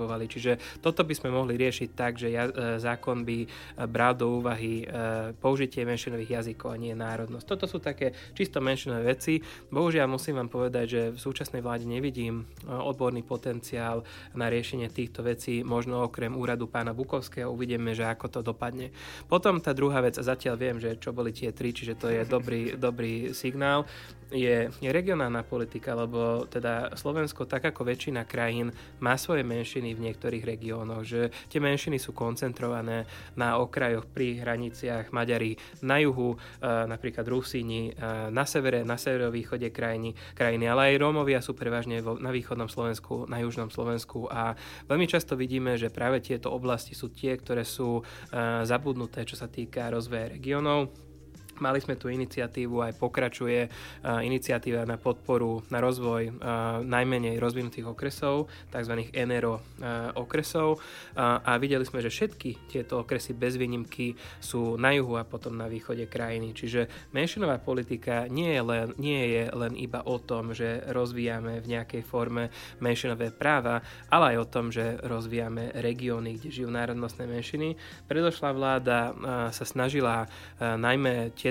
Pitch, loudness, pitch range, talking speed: 120 Hz, -30 LUFS, 115-130 Hz, 155 wpm